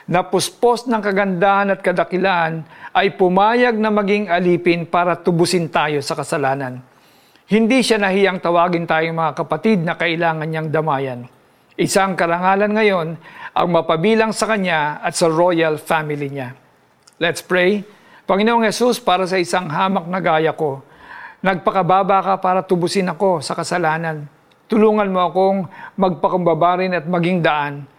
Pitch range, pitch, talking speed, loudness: 160-195 Hz, 180 Hz, 135 wpm, -17 LUFS